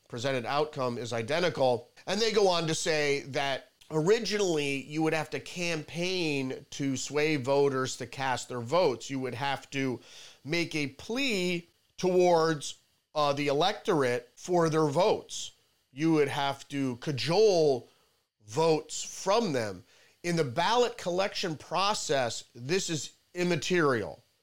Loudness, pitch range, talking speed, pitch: -29 LUFS, 135-175 Hz, 135 wpm, 150 Hz